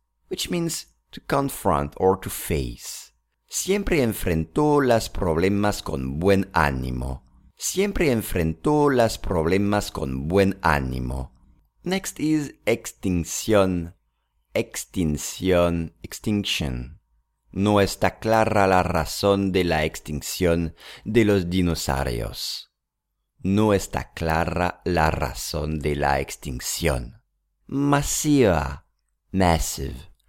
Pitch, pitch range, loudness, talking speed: 85 Hz, 75-100 Hz, -23 LUFS, 95 wpm